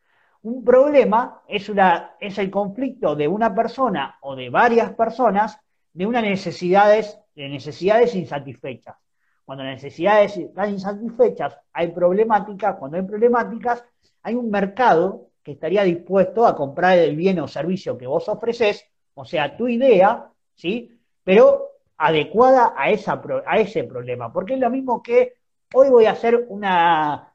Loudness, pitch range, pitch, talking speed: -19 LUFS, 175-235 Hz, 210 Hz, 150 wpm